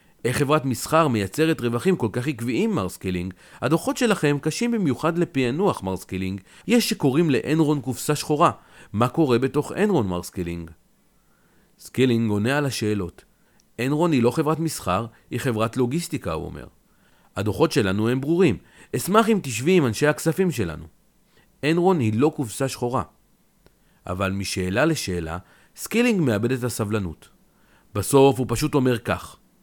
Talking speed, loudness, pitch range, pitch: 140 wpm, -23 LUFS, 105-160 Hz, 130 Hz